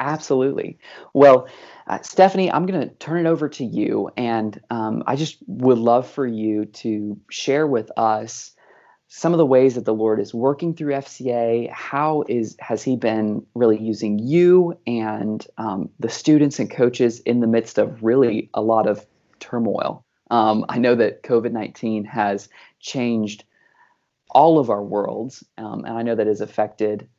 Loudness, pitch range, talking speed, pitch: -20 LUFS, 110-140 Hz, 170 wpm, 115 Hz